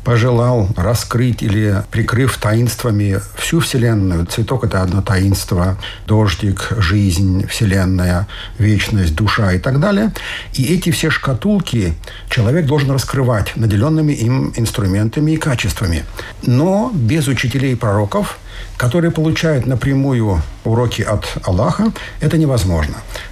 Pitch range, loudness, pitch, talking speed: 100-135 Hz, -16 LUFS, 115 Hz, 110 wpm